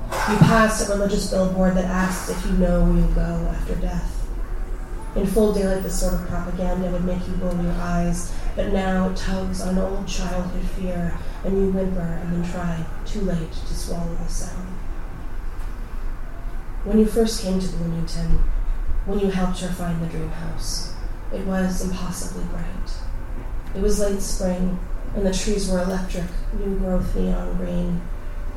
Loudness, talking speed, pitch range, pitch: -24 LUFS, 165 wpm, 155-190 Hz, 180 Hz